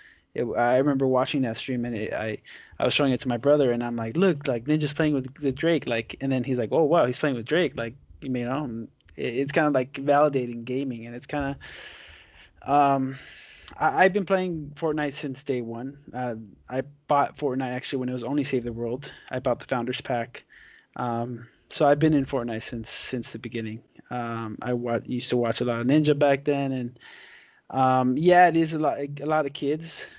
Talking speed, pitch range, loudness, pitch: 220 wpm, 120-145 Hz, -25 LUFS, 130 Hz